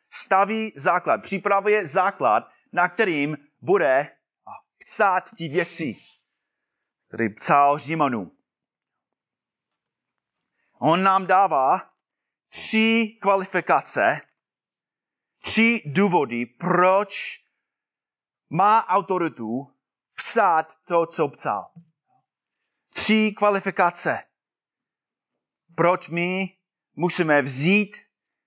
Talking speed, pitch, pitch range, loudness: 70 wpm, 180 Hz, 160-205 Hz, -22 LUFS